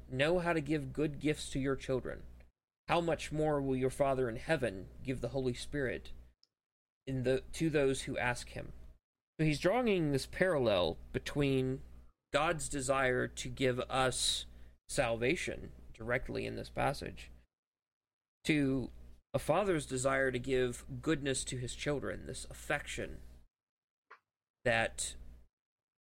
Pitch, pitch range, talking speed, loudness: 130 Hz, 95-145 Hz, 130 wpm, -35 LUFS